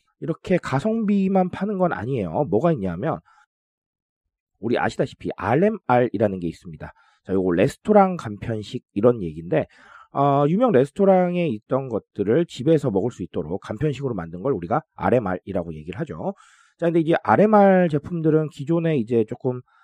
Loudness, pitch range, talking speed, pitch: -22 LUFS, 110-180 Hz, 350 characters per minute, 145 Hz